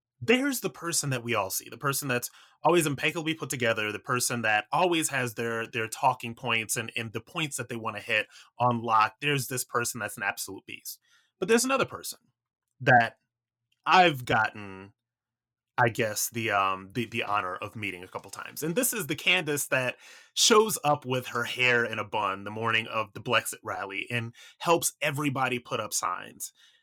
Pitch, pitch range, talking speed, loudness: 120 Hz, 115-150 Hz, 190 wpm, -27 LUFS